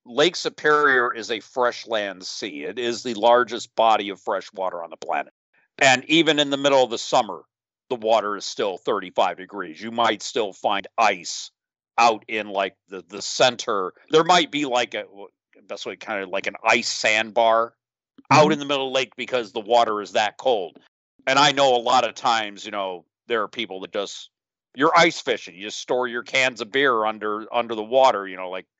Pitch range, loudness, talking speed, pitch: 105-130 Hz, -21 LUFS, 210 wpm, 120 Hz